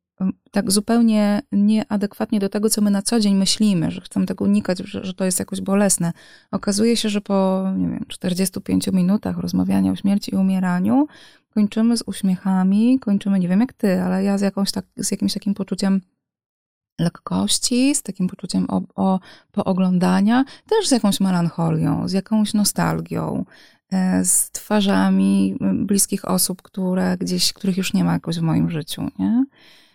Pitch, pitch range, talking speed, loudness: 195 Hz, 185-210 Hz, 160 wpm, -20 LUFS